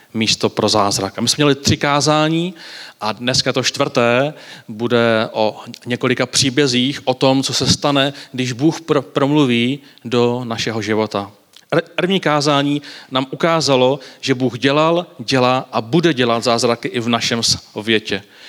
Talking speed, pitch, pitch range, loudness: 150 wpm, 130 Hz, 115-145 Hz, -16 LUFS